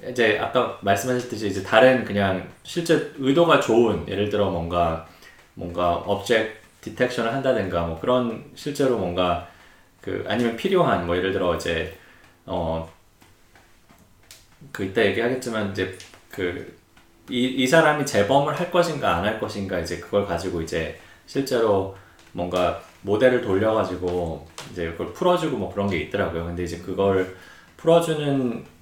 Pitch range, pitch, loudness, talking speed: 90-125 Hz, 100 Hz, -23 LUFS, 295 characters per minute